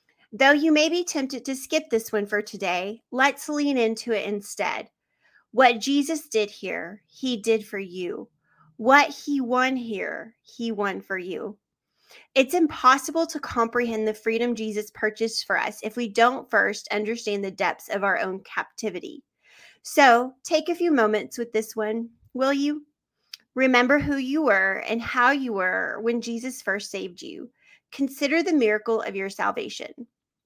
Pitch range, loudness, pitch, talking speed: 215-280 Hz, -24 LUFS, 235 Hz, 160 wpm